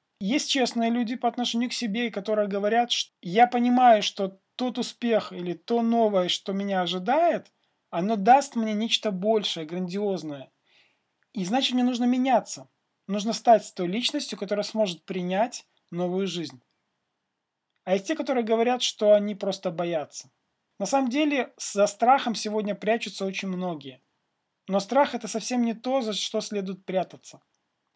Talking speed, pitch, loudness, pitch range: 150 wpm, 215 Hz, -25 LUFS, 195-240 Hz